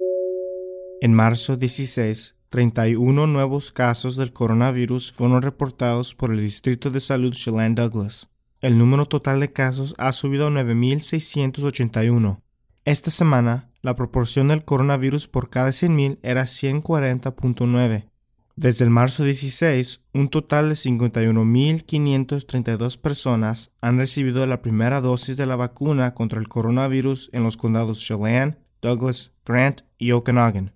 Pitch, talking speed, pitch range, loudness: 125 Hz, 125 wpm, 120-140 Hz, -20 LUFS